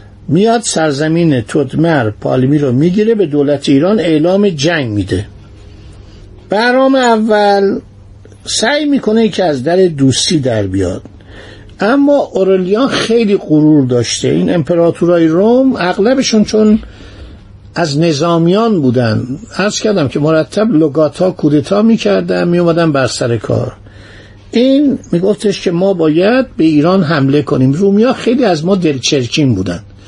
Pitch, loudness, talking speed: 160 Hz, -11 LUFS, 125 wpm